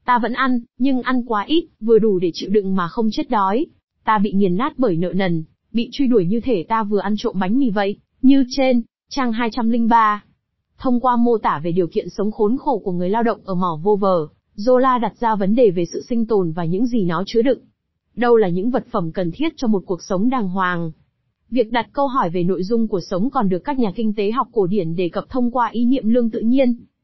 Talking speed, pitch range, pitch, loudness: 250 wpm, 190-245 Hz, 225 Hz, -19 LUFS